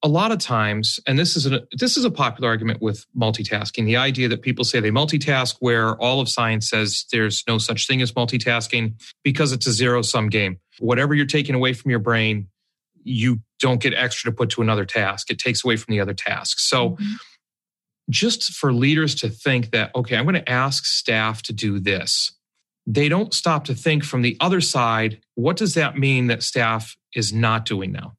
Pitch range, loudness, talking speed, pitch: 110-135 Hz, -20 LUFS, 205 wpm, 120 Hz